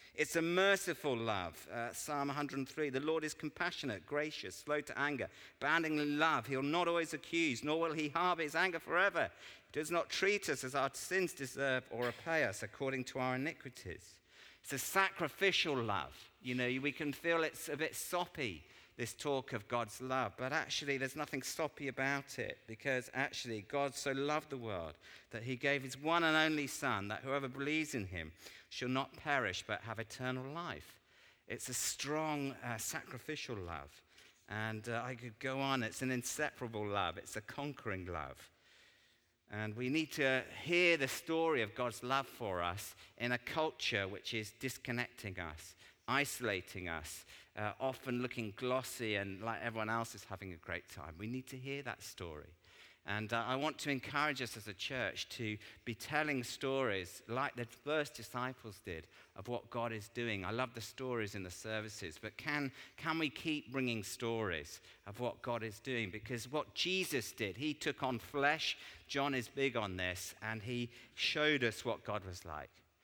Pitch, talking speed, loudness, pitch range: 130 Hz, 180 wpm, -38 LUFS, 110-145 Hz